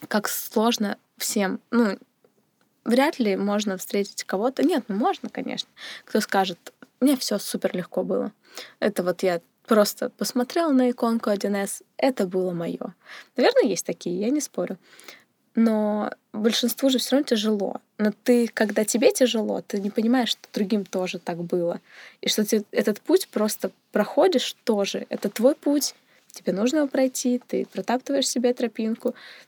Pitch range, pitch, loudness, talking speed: 205-255 Hz, 230 Hz, -24 LUFS, 155 wpm